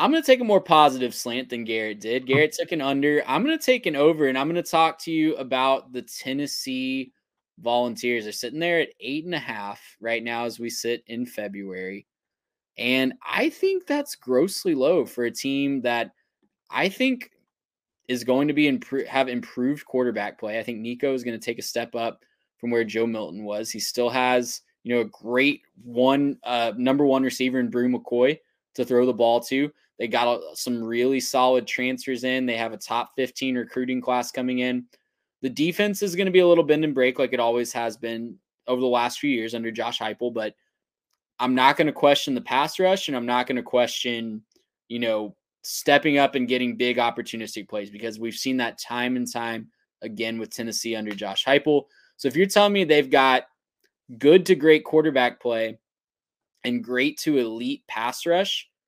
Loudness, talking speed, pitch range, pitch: -23 LUFS, 200 wpm, 120-145 Hz, 125 Hz